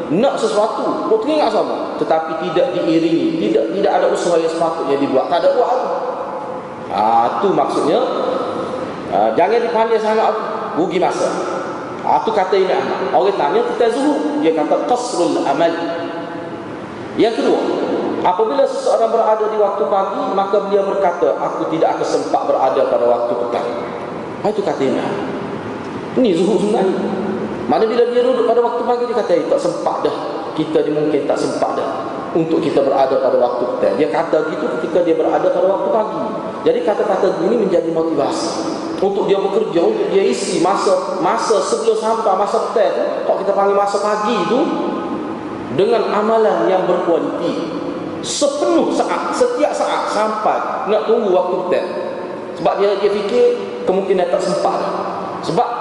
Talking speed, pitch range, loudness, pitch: 155 wpm, 170-235 Hz, -17 LUFS, 195 Hz